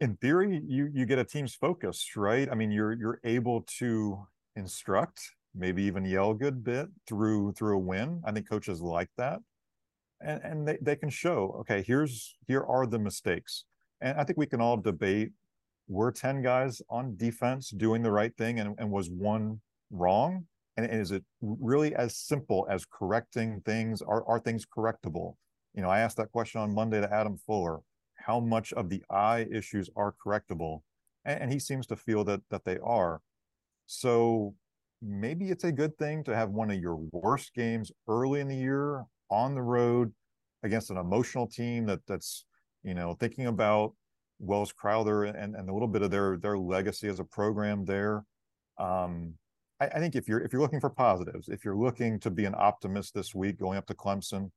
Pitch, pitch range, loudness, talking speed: 110 Hz, 100-125 Hz, -31 LUFS, 190 wpm